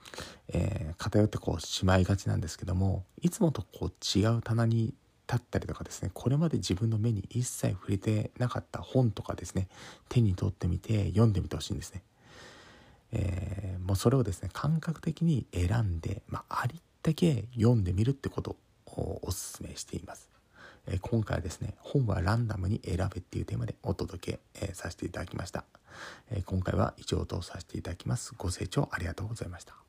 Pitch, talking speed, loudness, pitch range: 105 Hz, 385 characters per minute, -32 LUFS, 95-120 Hz